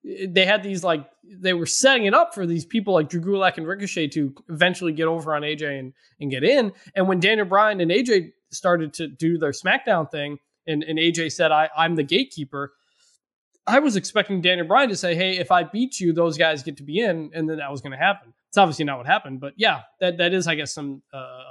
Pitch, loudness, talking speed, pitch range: 170 Hz, -21 LUFS, 240 wpm, 150-190 Hz